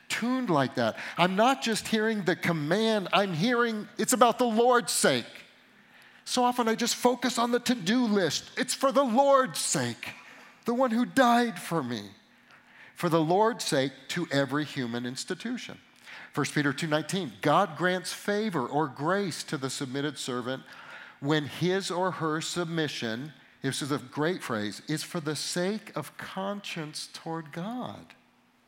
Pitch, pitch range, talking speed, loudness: 180 Hz, 150-230 Hz, 155 wpm, -28 LUFS